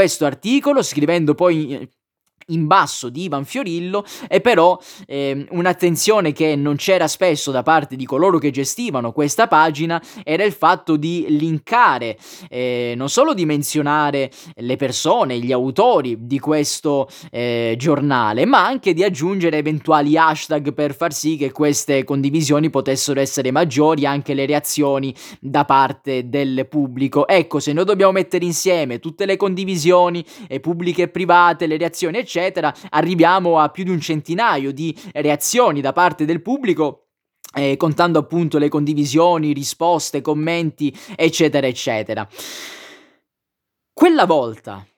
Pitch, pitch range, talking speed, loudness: 155 Hz, 140-175 Hz, 140 wpm, -17 LUFS